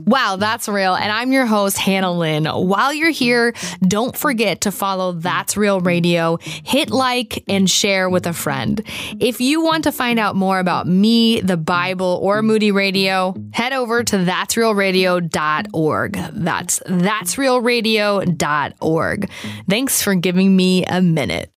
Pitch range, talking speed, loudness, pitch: 180-230 Hz, 150 wpm, -17 LUFS, 195 Hz